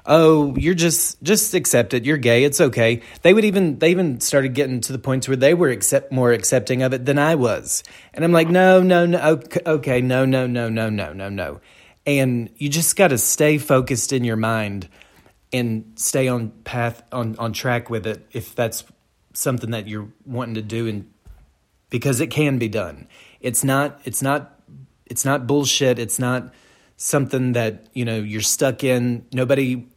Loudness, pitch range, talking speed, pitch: -19 LUFS, 115-145 Hz, 190 wpm, 125 Hz